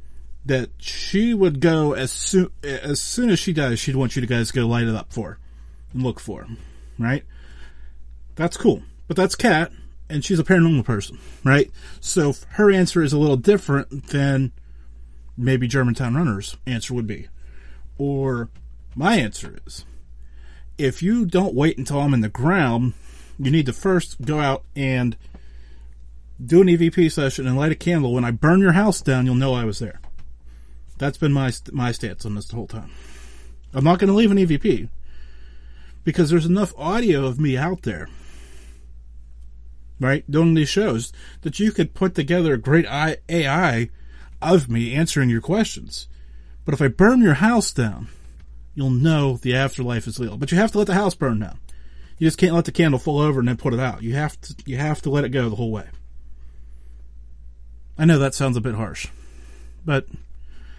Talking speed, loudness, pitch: 185 wpm, -20 LUFS, 125 Hz